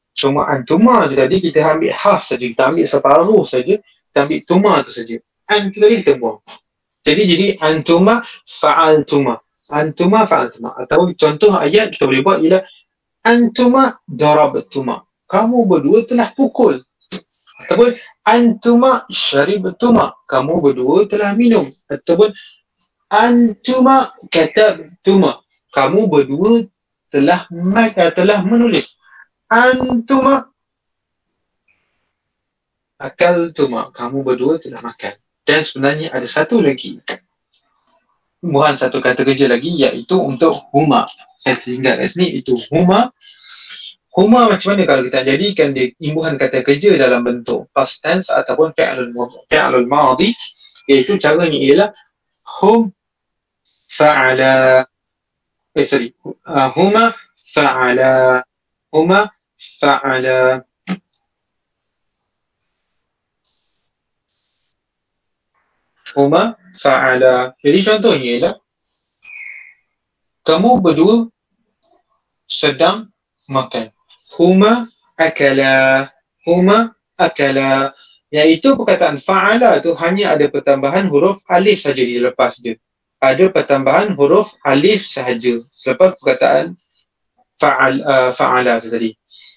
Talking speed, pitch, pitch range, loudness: 100 wpm, 170 Hz, 135-215 Hz, -13 LUFS